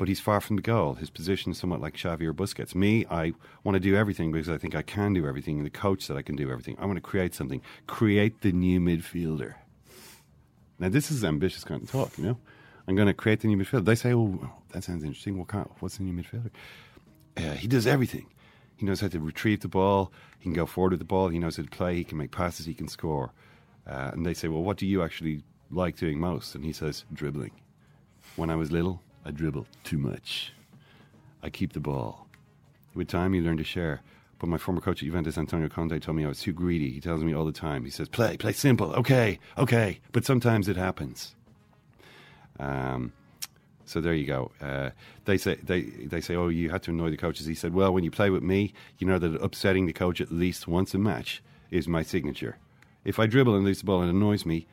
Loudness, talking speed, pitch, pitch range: -29 LUFS, 240 wpm, 90 Hz, 80-100 Hz